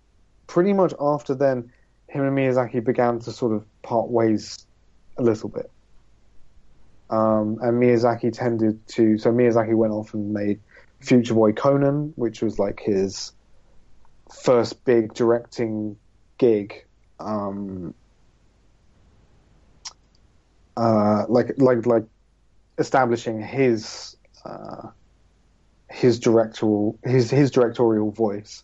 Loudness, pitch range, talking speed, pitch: -22 LUFS, 105-120 Hz, 110 wpm, 110 Hz